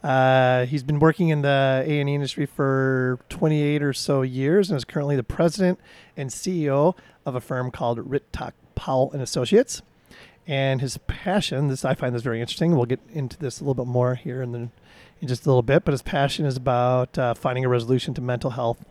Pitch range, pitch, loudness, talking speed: 125-145 Hz, 135 Hz, -23 LUFS, 205 wpm